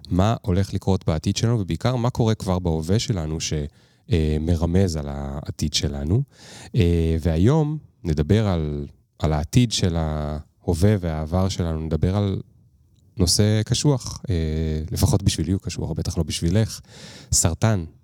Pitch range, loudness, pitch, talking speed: 80-110 Hz, -22 LUFS, 95 Hz, 120 wpm